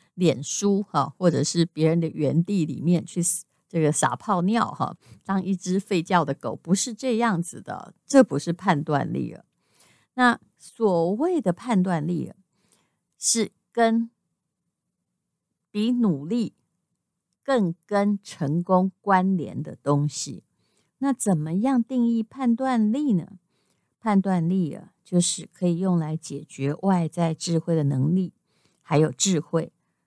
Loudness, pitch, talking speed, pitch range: -24 LUFS, 180 Hz, 195 characters per minute, 165-205 Hz